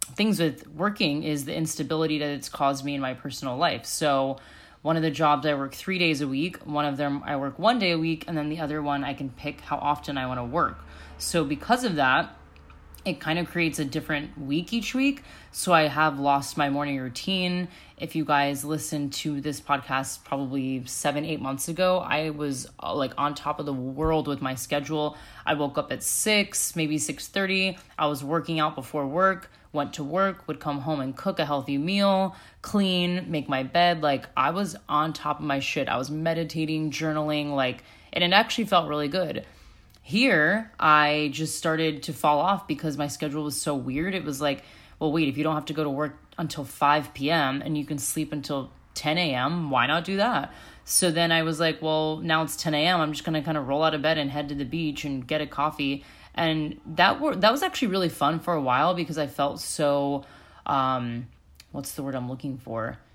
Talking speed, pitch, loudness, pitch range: 215 wpm, 150 Hz, -26 LUFS, 140-165 Hz